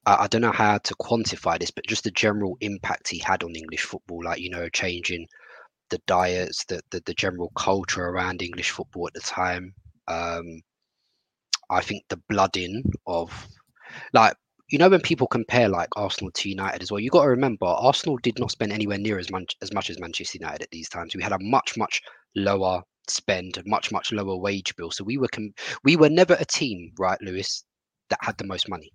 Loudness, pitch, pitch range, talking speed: -25 LUFS, 95 Hz, 90-110 Hz, 210 wpm